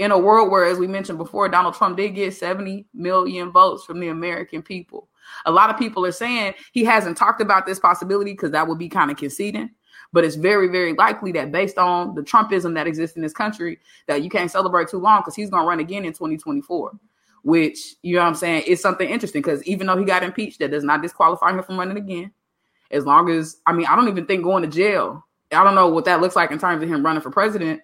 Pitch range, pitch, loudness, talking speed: 170-200 Hz, 185 Hz, -19 LUFS, 250 wpm